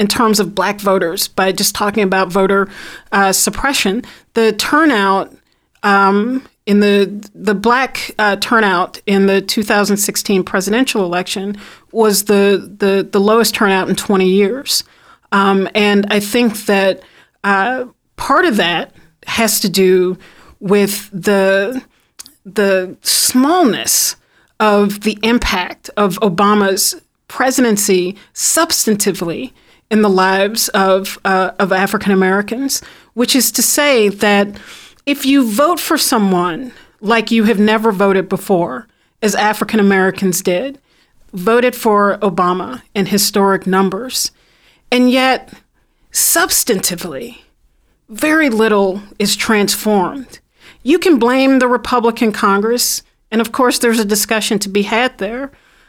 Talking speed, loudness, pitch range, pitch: 125 wpm, -13 LUFS, 195-235 Hz, 205 Hz